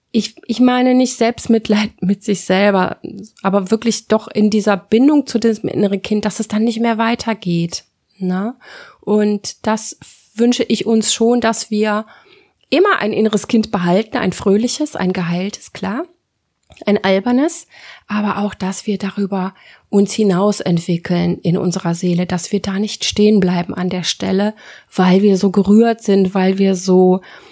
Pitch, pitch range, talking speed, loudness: 210 Hz, 190-225 Hz, 160 wpm, -16 LUFS